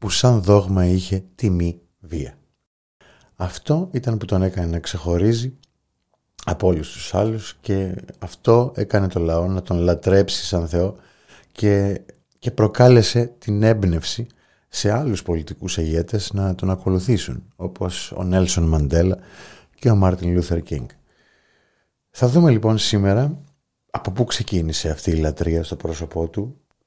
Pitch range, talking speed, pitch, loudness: 85-110 Hz, 135 wpm, 95 Hz, -20 LUFS